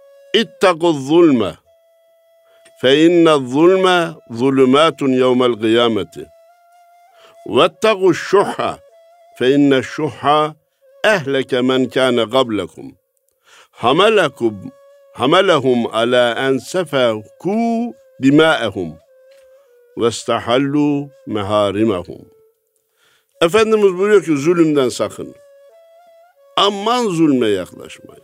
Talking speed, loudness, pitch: 65 wpm, -15 LUFS, 185 Hz